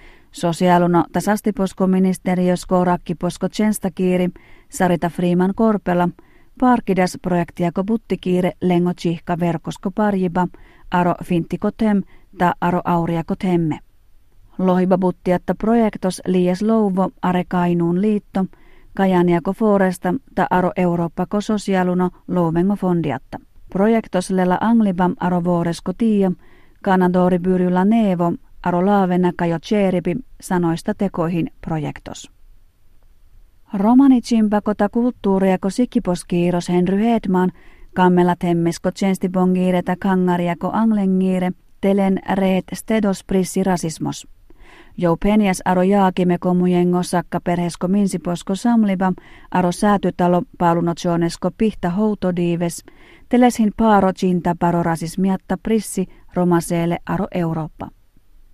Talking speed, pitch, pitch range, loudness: 90 wpm, 185 Hz, 175-195 Hz, -18 LUFS